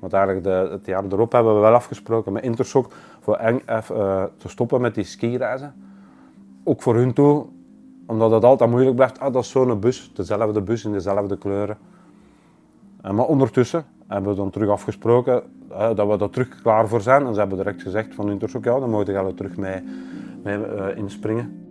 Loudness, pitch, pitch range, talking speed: -21 LUFS, 105 Hz, 100-125 Hz, 180 wpm